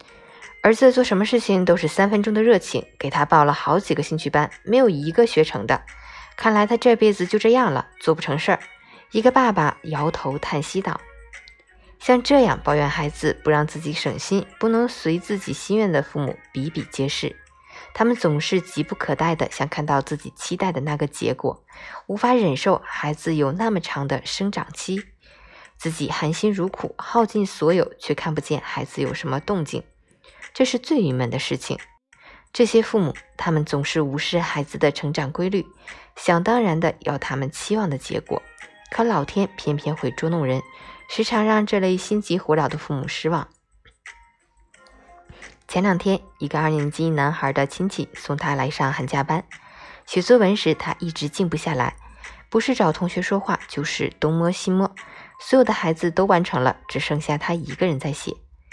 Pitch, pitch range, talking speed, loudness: 170 Hz, 150-210 Hz, 265 characters per minute, -21 LUFS